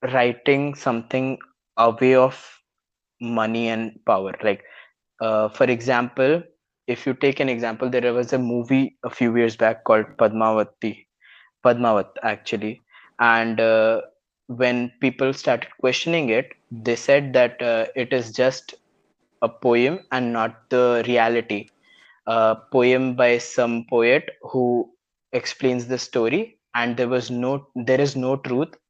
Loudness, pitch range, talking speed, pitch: -21 LUFS, 115-130 Hz, 135 wpm, 125 Hz